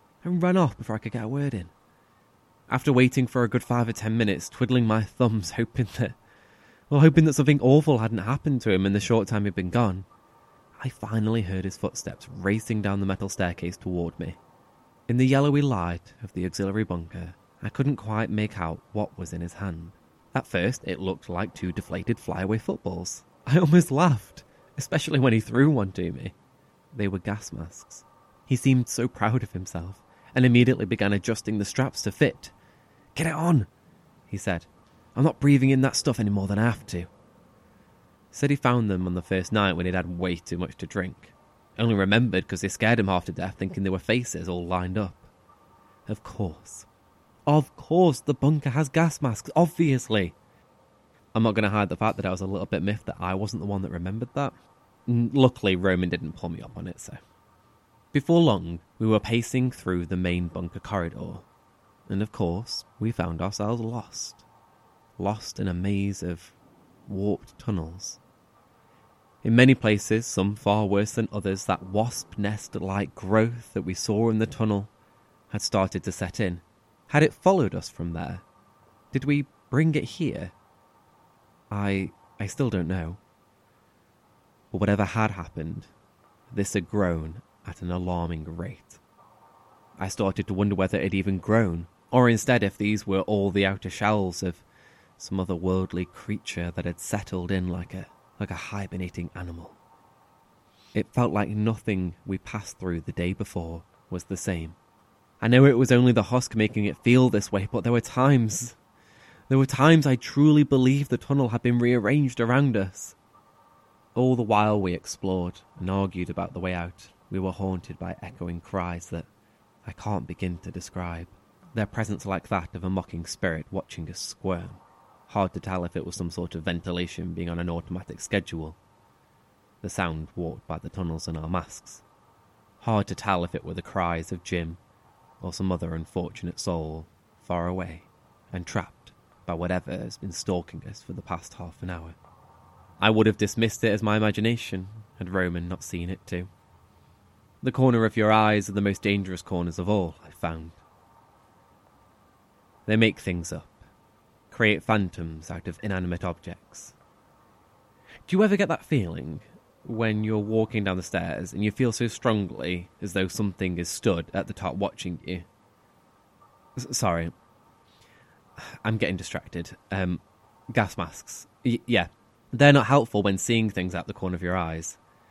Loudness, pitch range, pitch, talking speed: -26 LUFS, 90-115 Hz, 100 Hz, 180 wpm